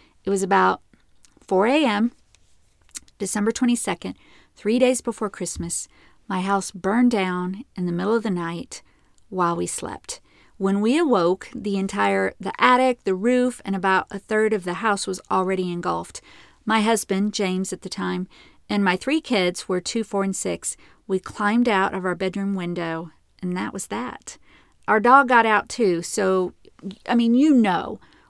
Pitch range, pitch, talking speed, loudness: 185-230 Hz, 195 Hz, 170 wpm, -22 LUFS